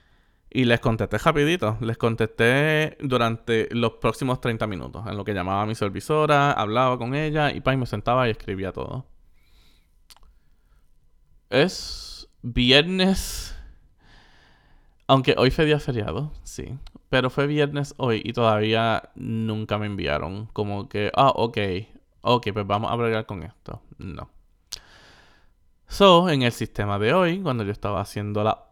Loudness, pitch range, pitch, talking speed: -23 LUFS, 100-130 Hz, 110 Hz, 140 wpm